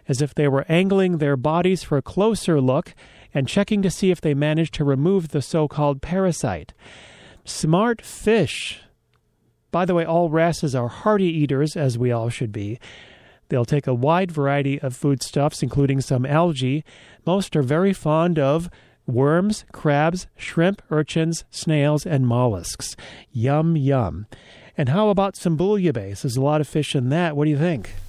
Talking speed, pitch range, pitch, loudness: 170 wpm, 135-175 Hz, 150 Hz, -21 LUFS